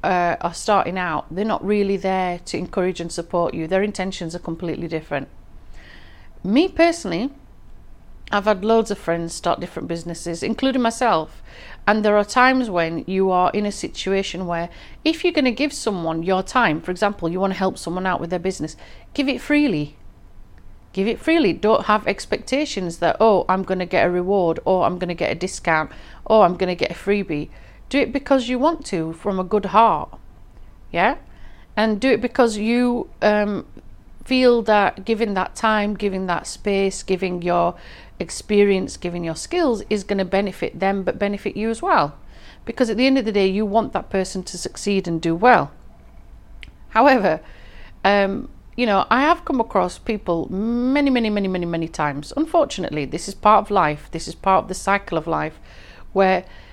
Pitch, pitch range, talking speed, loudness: 195 Hz, 170-220 Hz, 185 wpm, -20 LUFS